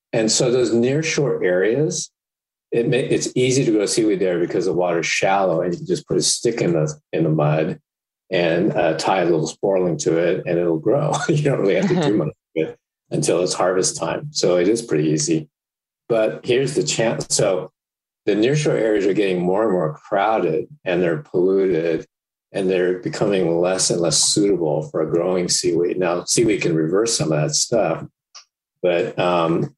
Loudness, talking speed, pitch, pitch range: -19 LUFS, 200 wpm, 95 Hz, 85-135 Hz